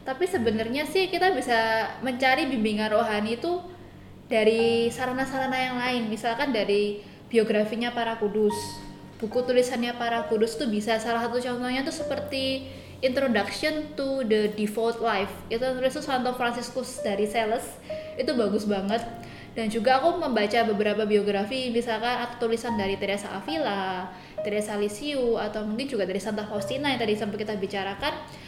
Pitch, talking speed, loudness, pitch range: 230 Hz, 145 wpm, -26 LUFS, 215-260 Hz